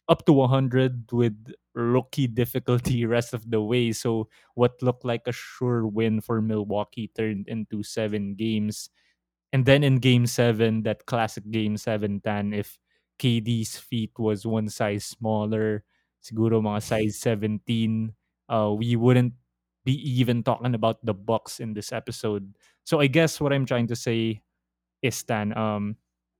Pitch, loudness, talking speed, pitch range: 115 Hz, -25 LUFS, 150 wpm, 105-125 Hz